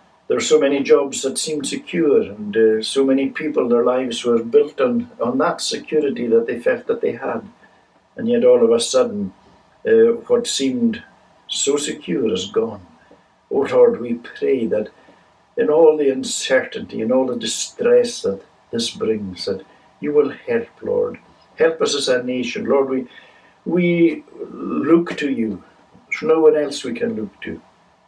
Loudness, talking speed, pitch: -19 LUFS, 175 wpm, 235 Hz